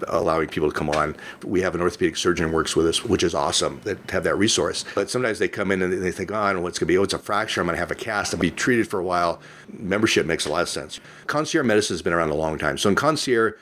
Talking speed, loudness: 280 wpm, -22 LUFS